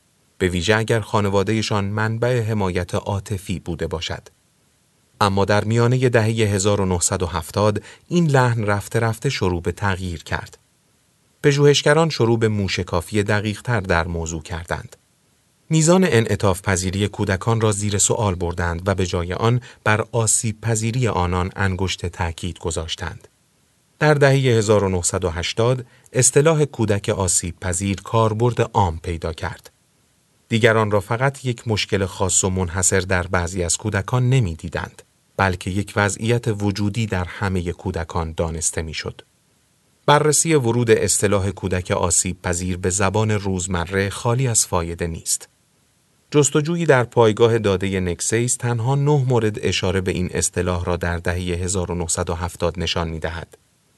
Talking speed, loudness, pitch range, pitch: 130 wpm, -20 LUFS, 90-115 Hz, 100 Hz